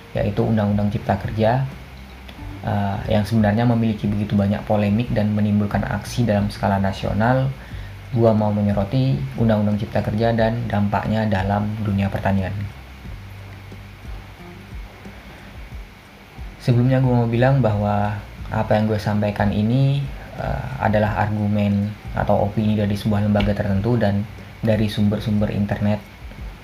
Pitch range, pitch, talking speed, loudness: 100-110 Hz, 105 Hz, 115 wpm, -20 LUFS